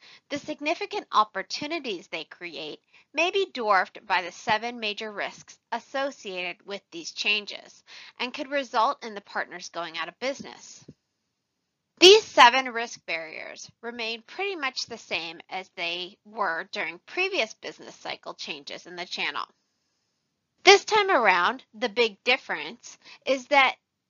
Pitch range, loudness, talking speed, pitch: 195-285 Hz, -25 LUFS, 135 wpm, 230 Hz